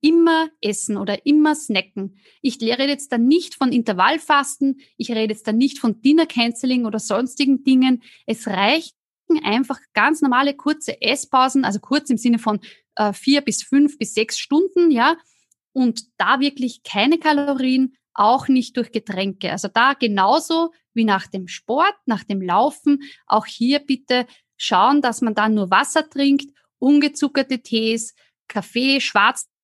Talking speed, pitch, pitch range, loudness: 150 wpm, 255 Hz, 220-285 Hz, -19 LUFS